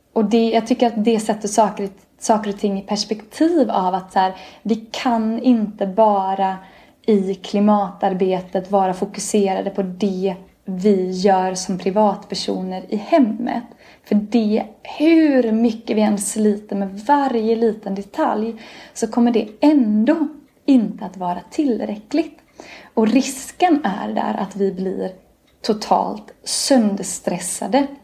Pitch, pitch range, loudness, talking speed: 215 Hz, 195-240 Hz, -19 LUFS, 130 wpm